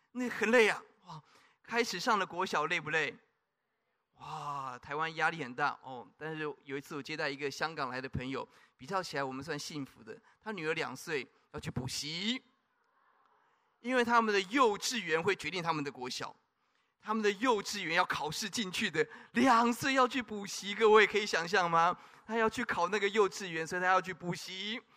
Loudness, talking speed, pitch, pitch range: -32 LUFS, 275 characters per minute, 190 Hz, 155-225 Hz